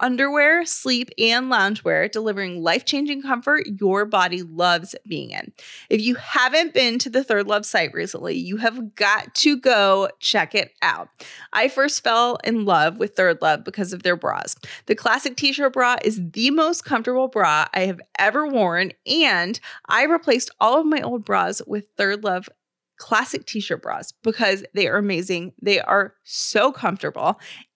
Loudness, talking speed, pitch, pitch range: -20 LUFS, 175 wpm, 225 Hz, 195-270 Hz